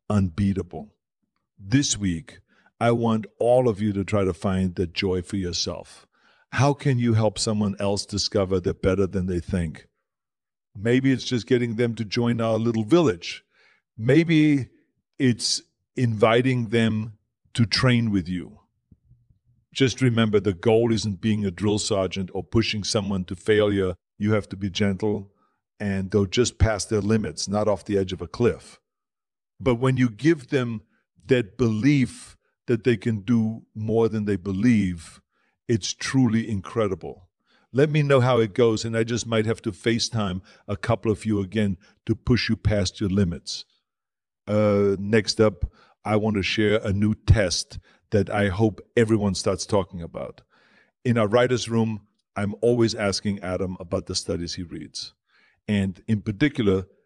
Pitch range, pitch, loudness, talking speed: 100-115 Hz, 110 Hz, -23 LUFS, 160 wpm